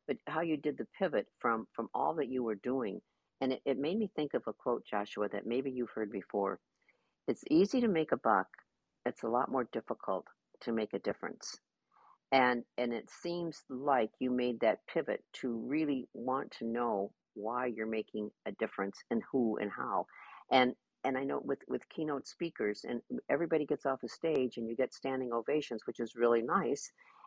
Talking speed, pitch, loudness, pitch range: 195 wpm, 125 Hz, -35 LUFS, 115-140 Hz